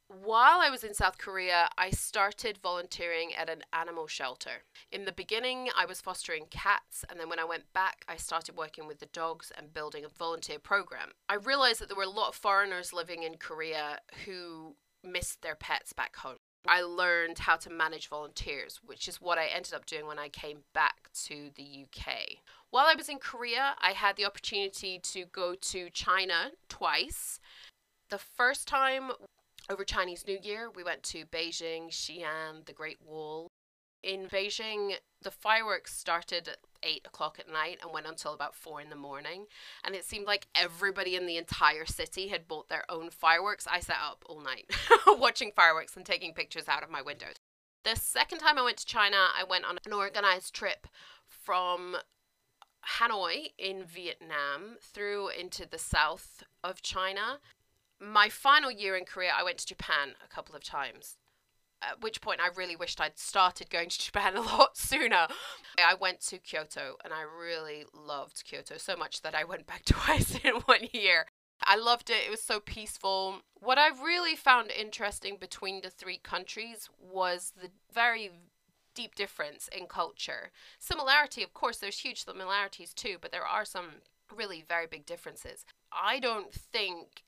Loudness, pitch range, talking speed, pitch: -31 LUFS, 165-205 Hz, 180 wpm, 185 Hz